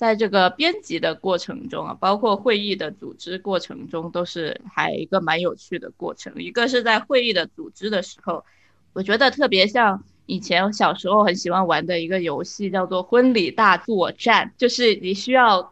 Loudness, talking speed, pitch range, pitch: -20 LUFS, 290 characters per minute, 180-240 Hz, 195 Hz